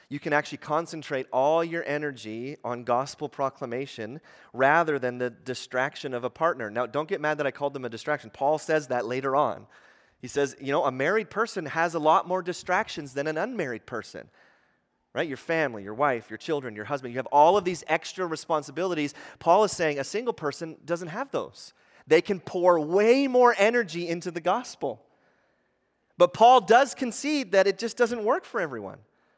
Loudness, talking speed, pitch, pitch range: -26 LUFS, 190 wpm, 155 Hz, 135-180 Hz